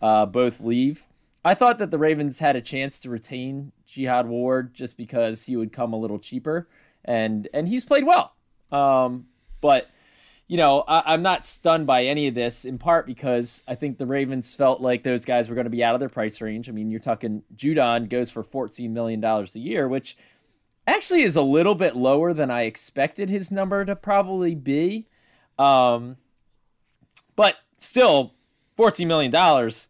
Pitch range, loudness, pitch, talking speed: 120-155 Hz, -22 LUFS, 130 Hz, 185 wpm